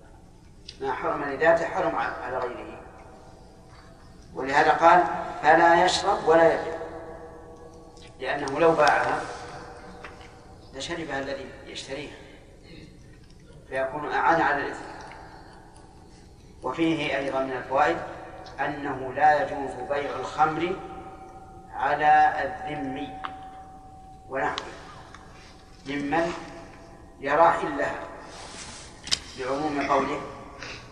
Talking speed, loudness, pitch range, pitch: 75 wpm, -25 LUFS, 140-165 Hz, 150 Hz